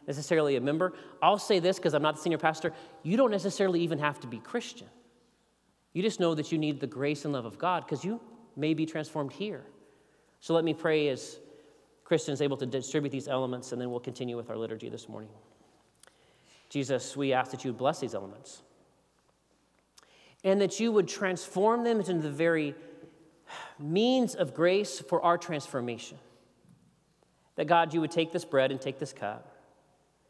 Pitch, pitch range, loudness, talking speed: 160 Hz, 135-180 Hz, -30 LUFS, 180 wpm